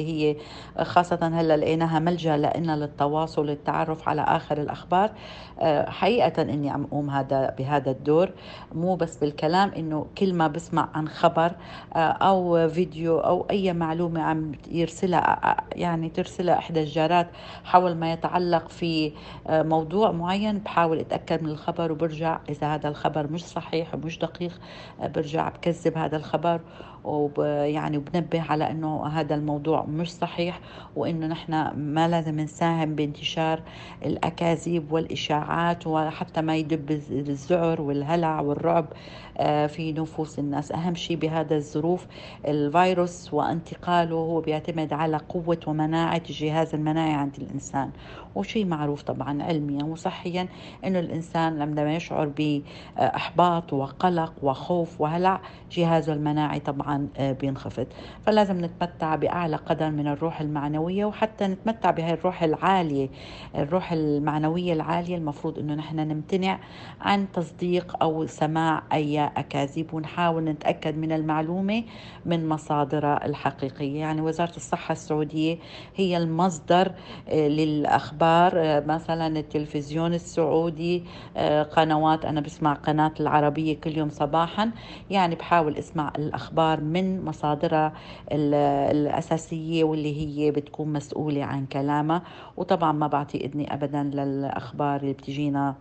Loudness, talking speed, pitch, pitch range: -26 LUFS, 120 wpm, 160 Hz, 150-170 Hz